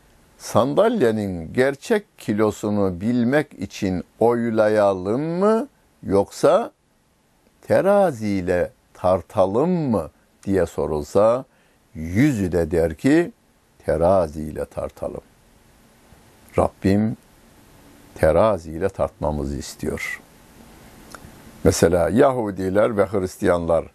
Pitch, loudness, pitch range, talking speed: 105 Hz, -21 LUFS, 90-120 Hz, 70 wpm